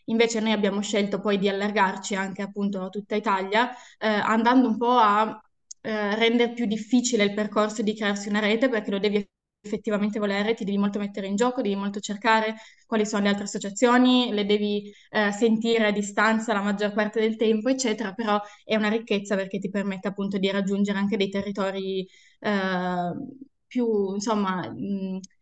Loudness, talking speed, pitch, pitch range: -25 LUFS, 175 wpm, 210 Hz, 200-220 Hz